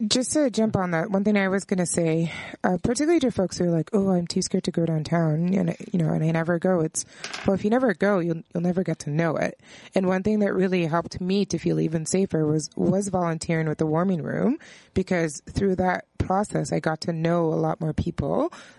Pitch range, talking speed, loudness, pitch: 165-195 Hz, 245 wpm, -24 LUFS, 180 Hz